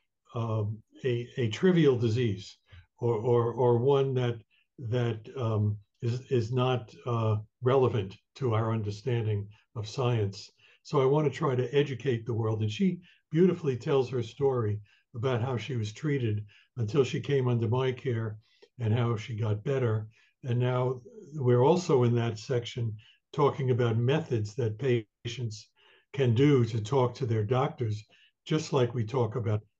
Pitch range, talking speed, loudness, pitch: 110-130 Hz, 155 wpm, -29 LUFS, 120 Hz